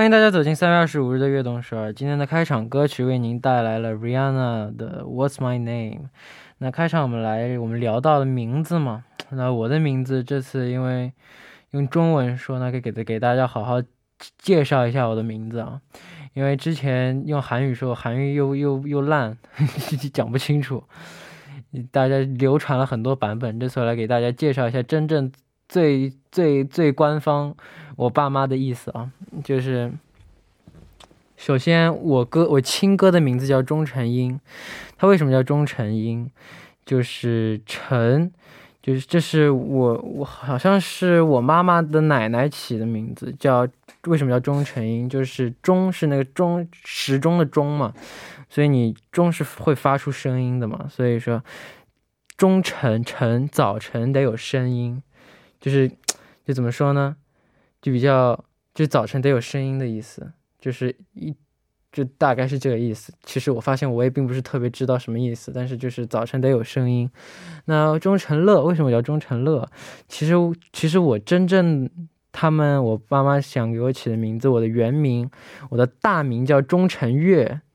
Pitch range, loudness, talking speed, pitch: 125-150 Hz, -21 LUFS, 260 characters per minute, 135 Hz